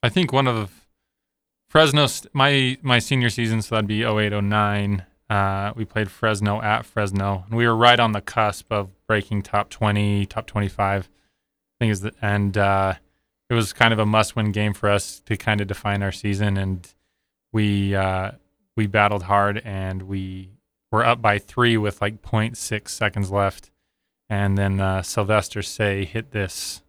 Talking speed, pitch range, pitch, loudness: 185 wpm, 100-110 Hz, 105 Hz, -21 LUFS